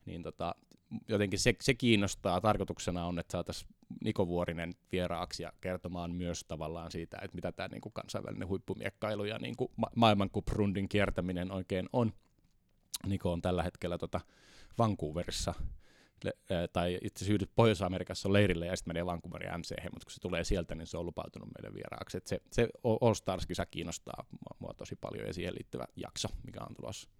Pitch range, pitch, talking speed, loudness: 85-105 Hz, 90 Hz, 170 wpm, -35 LUFS